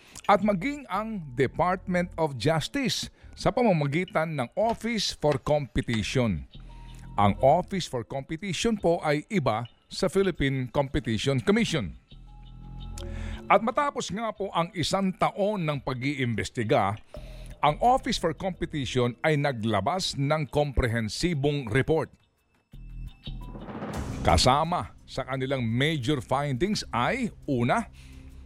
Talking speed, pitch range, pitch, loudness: 100 wpm, 130-180 Hz, 145 Hz, -27 LUFS